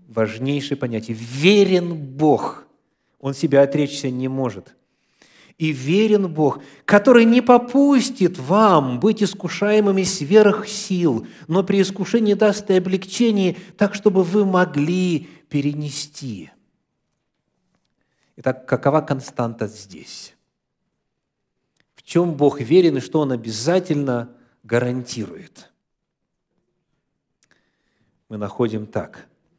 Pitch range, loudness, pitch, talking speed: 130-195 Hz, -19 LUFS, 155 Hz, 95 wpm